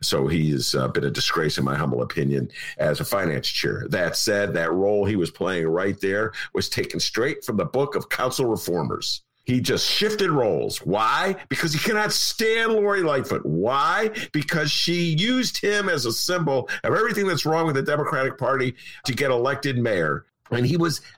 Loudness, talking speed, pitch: -23 LUFS, 190 wpm, 150 Hz